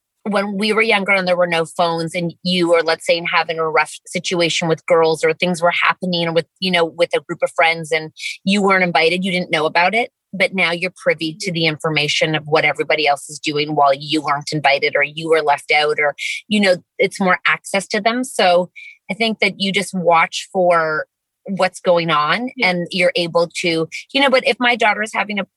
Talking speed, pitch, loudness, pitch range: 225 wpm, 175 Hz, -17 LUFS, 160-190 Hz